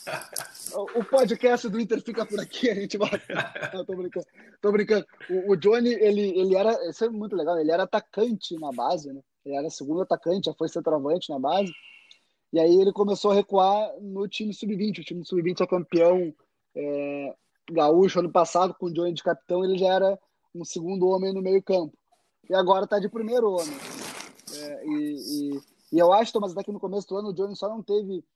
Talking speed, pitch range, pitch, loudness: 200 wpm, 175-210 Hz, 195 Hz, -25 LUFS